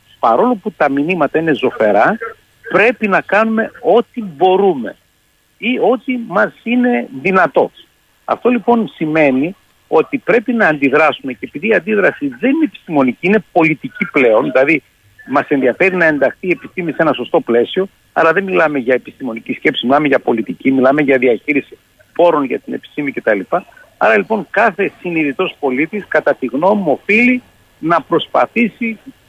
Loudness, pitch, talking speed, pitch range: -14 LUFS, 190 Hz, 150 wpm, 150-240 Hz